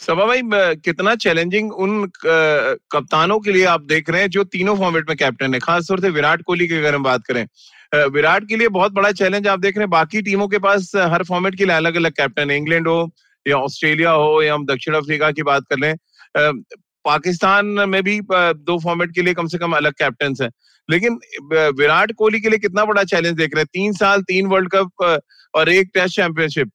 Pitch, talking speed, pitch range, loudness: 175 Hz, 210 wpm, 155-200 Hz, -16 LUFS